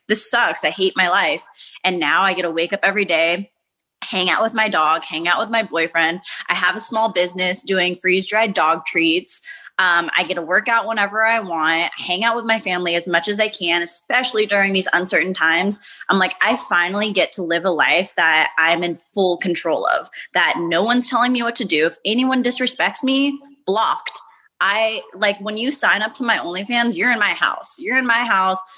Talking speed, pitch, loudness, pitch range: 215 wpm, 190 Hz, -18 LUFS, 175-225 Hz